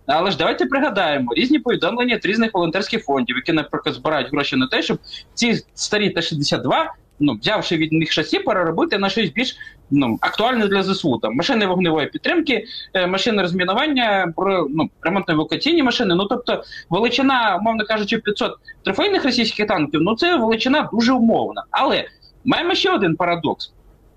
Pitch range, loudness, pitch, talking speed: 170-255 Hz, -19 LUFS, 210 Hz, 155 wpm